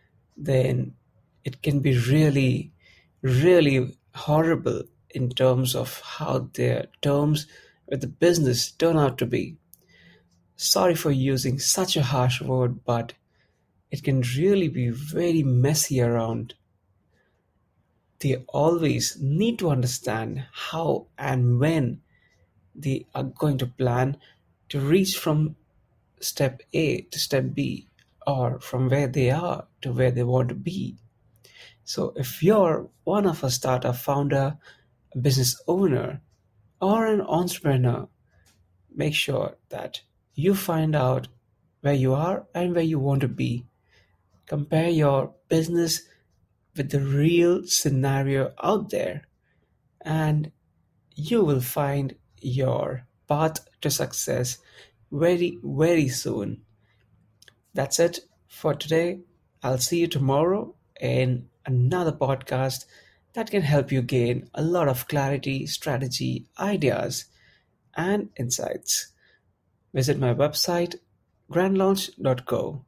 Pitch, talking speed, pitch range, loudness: 135 Hz, 120 wpm, 120-155 Hz, -24 LUFS